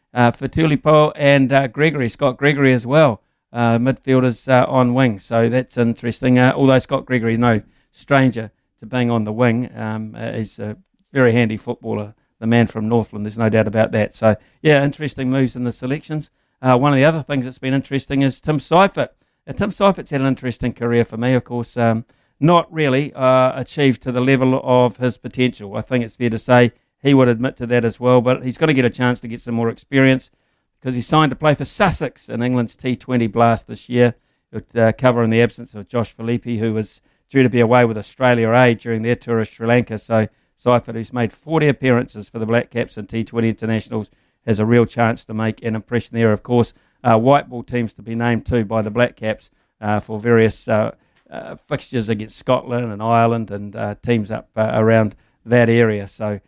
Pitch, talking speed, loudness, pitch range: 120 Hz, 215 wpm, -18 LUFS, 115-130 Hz